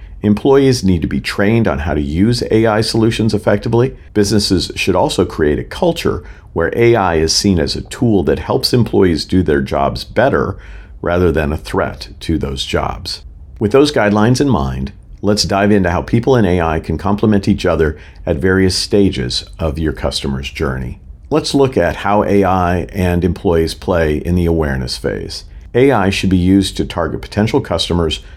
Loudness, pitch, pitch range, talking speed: -14 LUFS, 95 Hz, 80-105 Hz, 175 wpm